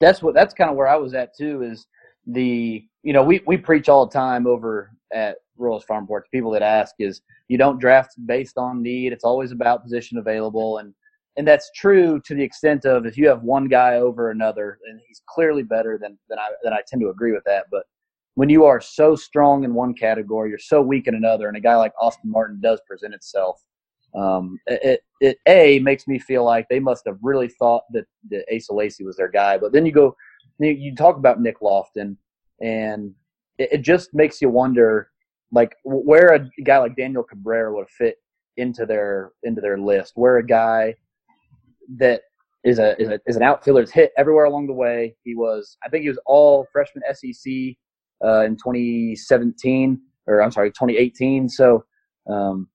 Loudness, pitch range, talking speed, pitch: -18 LUFS, 110-140 Hz, 200 wpm, 125 Hz